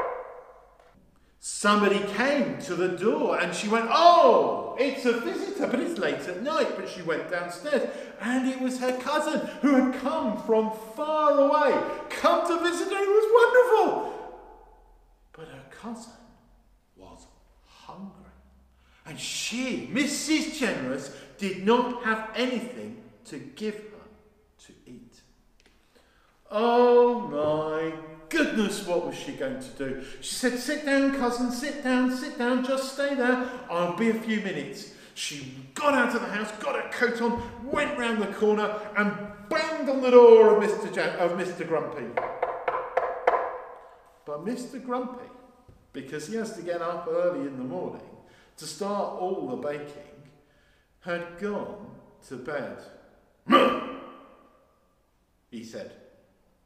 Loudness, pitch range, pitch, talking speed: -25 LUFS, 175-265 Hz, 225 Hz, 140 wpm